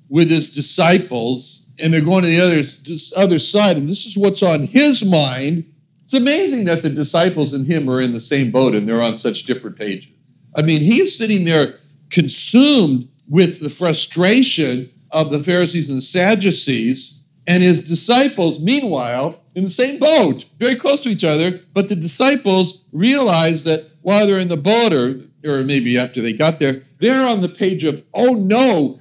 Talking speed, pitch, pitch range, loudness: 180 wpm, 170 Hz, 145-200 Hz, -16 LUFS